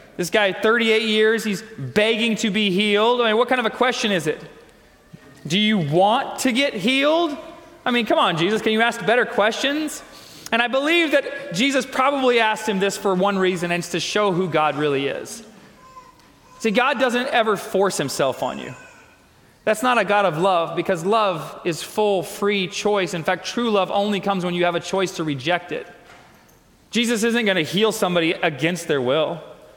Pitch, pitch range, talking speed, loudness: 210 Hz, 185-240 Hz, 195 wpm, -20 LUFS